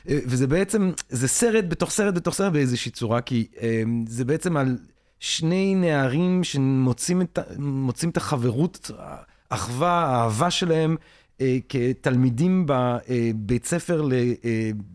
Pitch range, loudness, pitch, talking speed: 120-175 Hz, -23 LUFS, 135 Hz, 125 wpm